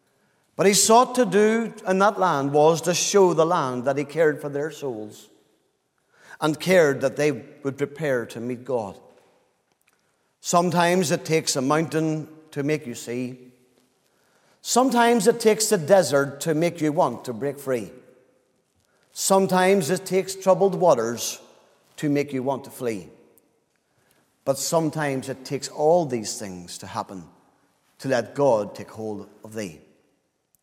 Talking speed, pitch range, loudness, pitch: 150 wpm, 125-185 Hz, -22 LUFS, 150 Hz